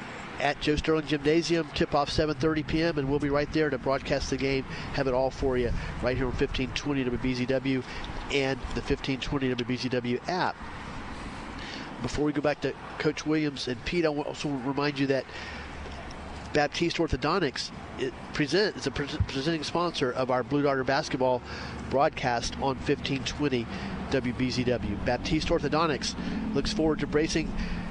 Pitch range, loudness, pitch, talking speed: 125-150 Hz, -29 LUFS, 135 Hz, 150 wpm